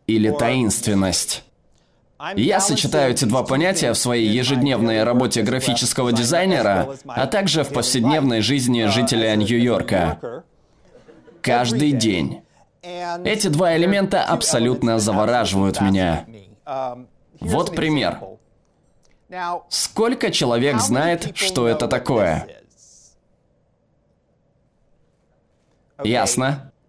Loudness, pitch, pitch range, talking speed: -19 LUFS, 125 Hz, 115-155 Hz, 85 wpm